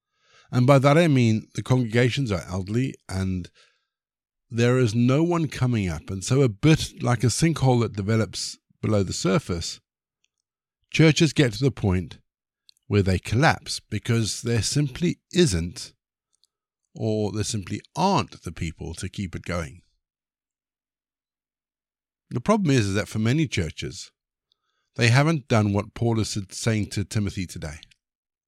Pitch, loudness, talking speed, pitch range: 110 Hz, -23 LUFS, 145 wpm, 95-135 Hz